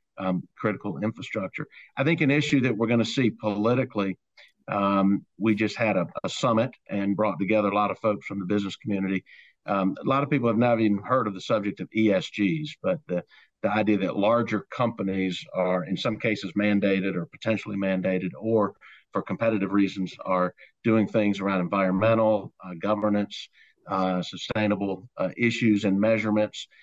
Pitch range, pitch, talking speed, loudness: 95-115 Hz, 105 Hz, 170 wpm, -26 LUFS